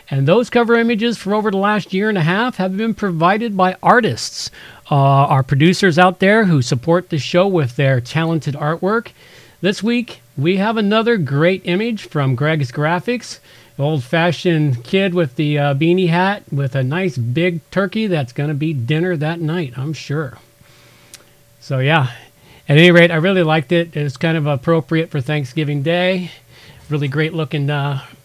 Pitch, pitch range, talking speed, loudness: 165 Hz, 145-185 Hz, 170 wpm, -16 LUFS